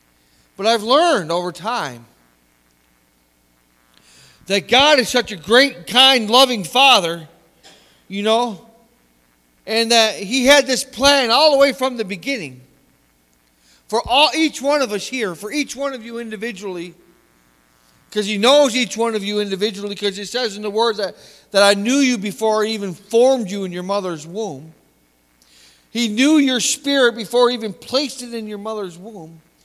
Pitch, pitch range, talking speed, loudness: 210 Hz, 160-245 Hz, 165 wpm, -16 LUFS